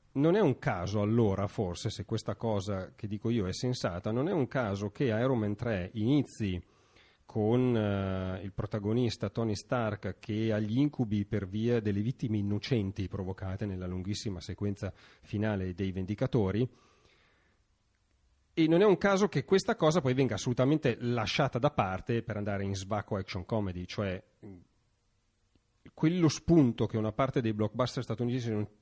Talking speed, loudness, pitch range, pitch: 155 wpm, -31 LUFS, 100-125 Hz, 110 Hz